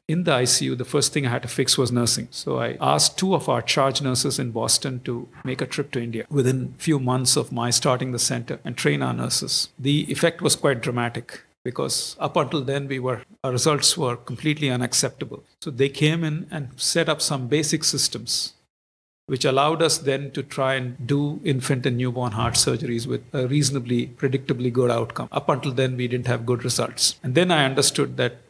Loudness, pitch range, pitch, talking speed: -22 LUFS, 125-145 Hz, 135 Hz, 210 wpm